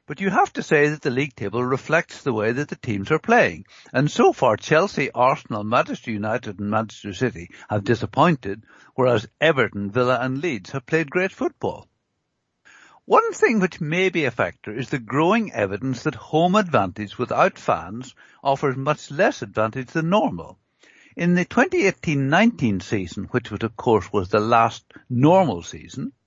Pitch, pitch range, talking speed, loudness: 135 Hz, 110-175 Hz, 165 wpm, -21 LUFS